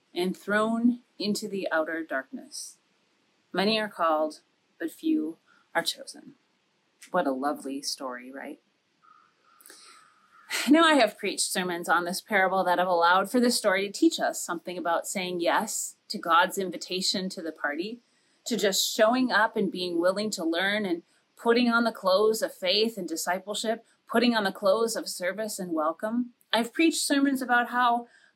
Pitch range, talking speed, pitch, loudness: 180-245 Hz, 160 wpm, 210 Hz, -26 LUFS